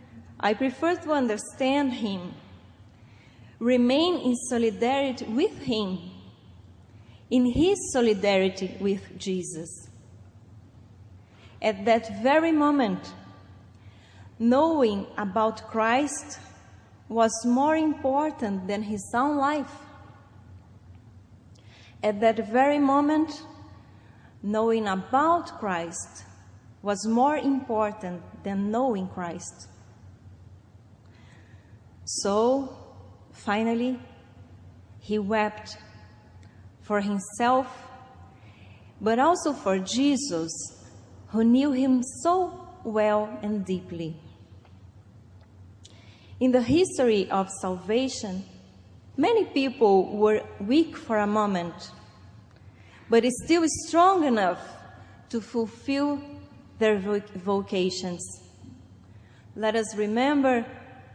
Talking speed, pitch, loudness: 80 wpm, 205 Hz, -25 LUFS